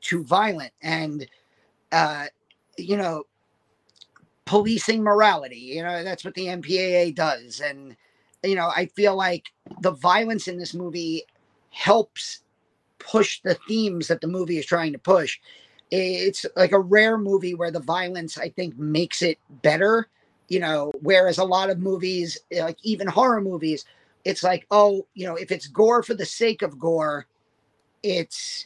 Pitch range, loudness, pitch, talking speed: 165-200 Hz, -23 LUFS, 180 Hz, 155 wpm